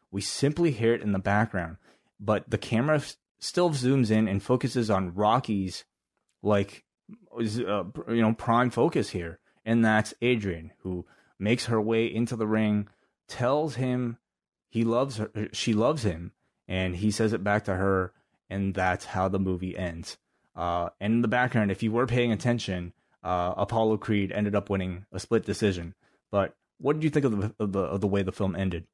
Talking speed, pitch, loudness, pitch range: 185 wpm, 105 Hz, -28 LUFS, 95-115 Hz